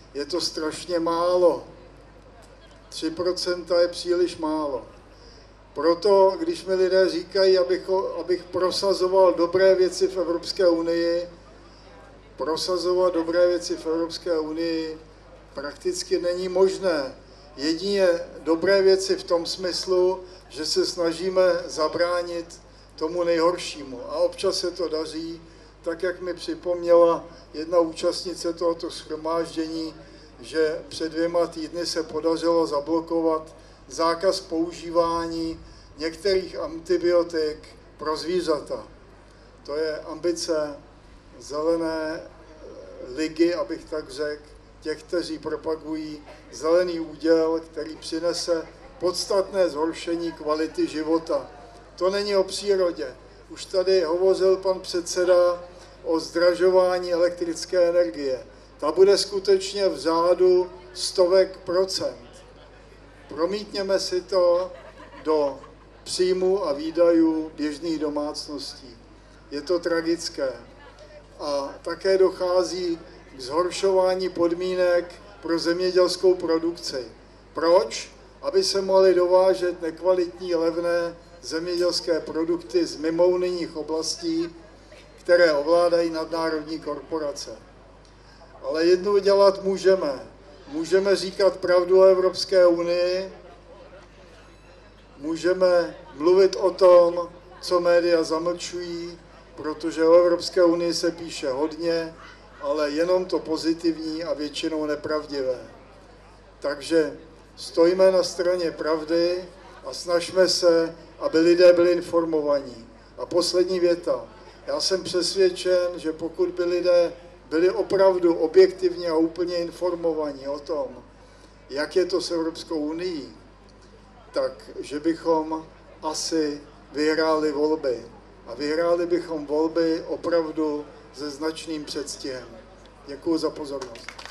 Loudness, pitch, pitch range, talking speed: -23 LUFS, 170 Hz, 160-180 Hz, 100 wpm